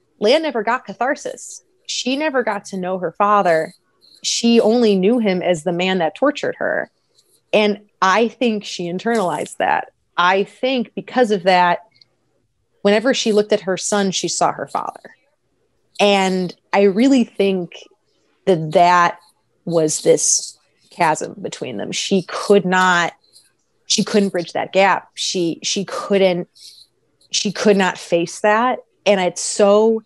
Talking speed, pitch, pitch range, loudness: 145 wpm, 200 Hz, 180-220 Hz, -17 LUFS